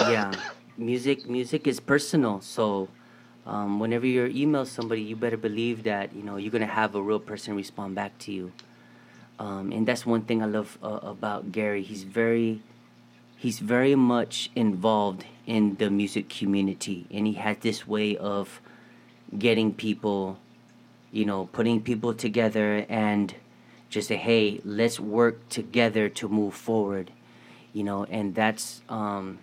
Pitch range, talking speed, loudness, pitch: 100-115 Hz, 155 wpm, -27 LUFS, 110 Hz